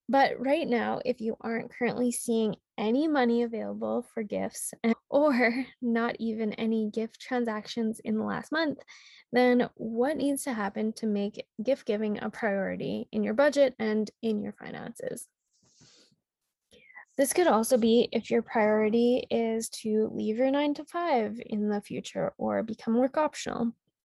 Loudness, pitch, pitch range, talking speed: -29 LUFS, 230 Hz, 220-255 Hz, 155 wpm